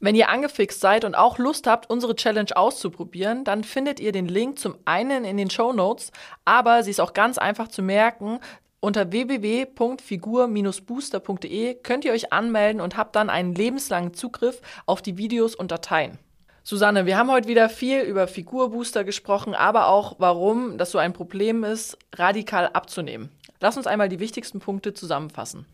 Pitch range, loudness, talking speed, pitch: 195-235 Hz, -23 LUFS, 170 wpm, 215 Hz